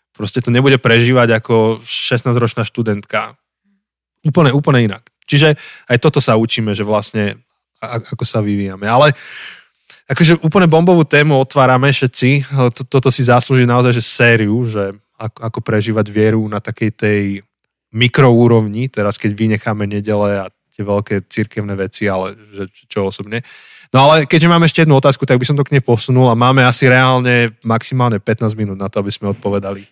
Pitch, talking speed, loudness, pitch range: 120 Hz, 160 wpm, -13 LUFS, 105-130 Hz